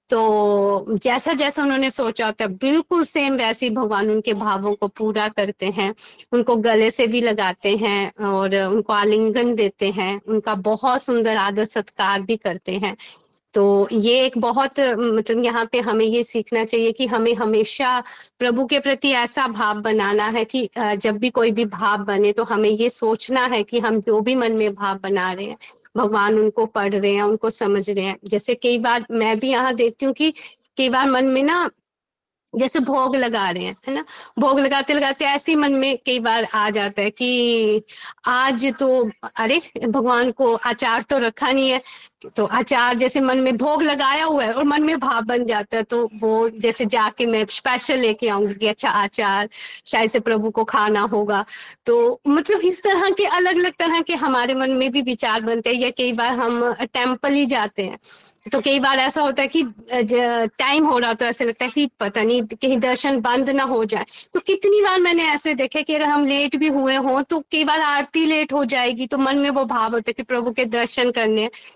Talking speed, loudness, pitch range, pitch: 205 wpm, -19 LUFS, 215-270 Hz, 240 Hz